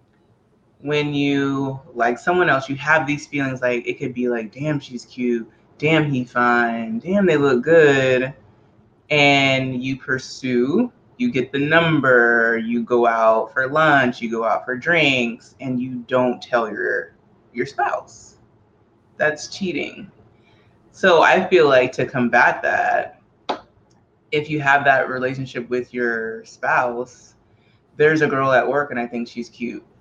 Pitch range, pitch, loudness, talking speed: 120-140 Hz, 125 Hz, -19 LUFS, 150 wpm